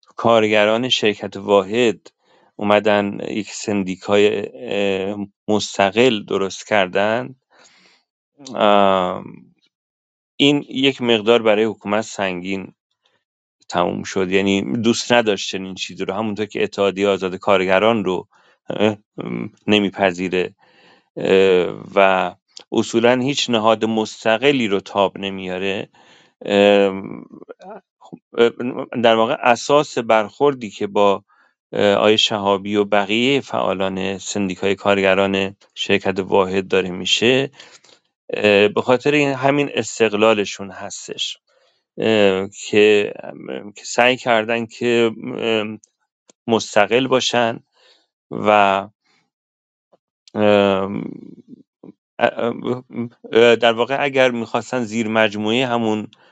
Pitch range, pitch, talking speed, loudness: 95-115 Hz, 105 Hz, 80 wpm, -18 LUFS